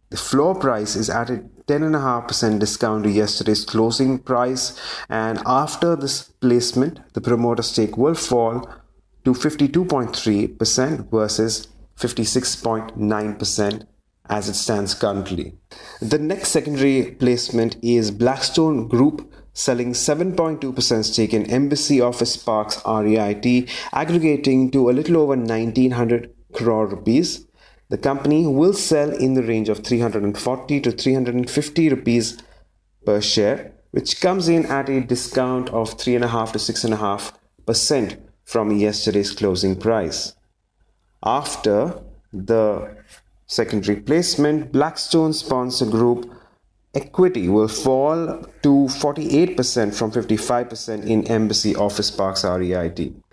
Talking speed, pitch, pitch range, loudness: 110 wpm, 120 Hz, 105-135 Hz, -20 LUFS